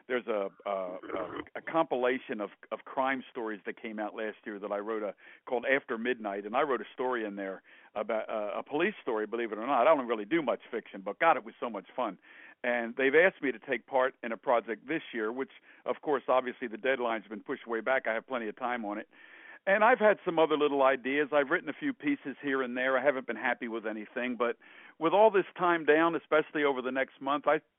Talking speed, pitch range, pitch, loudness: 245 wpm, 115-150 Hz, 130 Hz, -31 LUFS